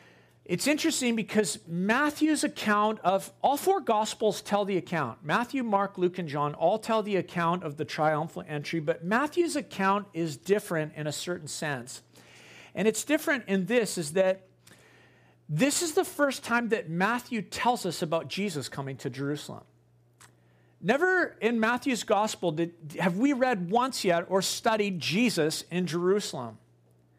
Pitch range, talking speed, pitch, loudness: 150-225 Hz, 155 wpm, 185 Hz, -28 LUFS